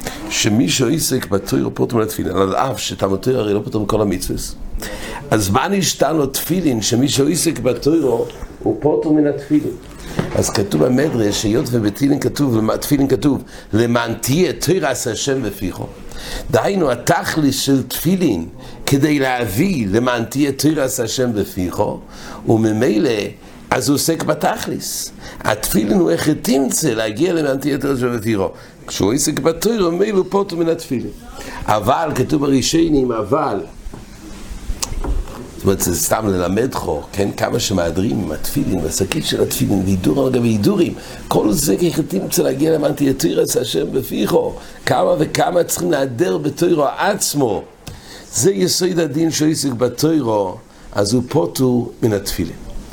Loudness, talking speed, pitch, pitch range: -17 LUFS, 135 wpm, 135 Hz, 110-160 Hz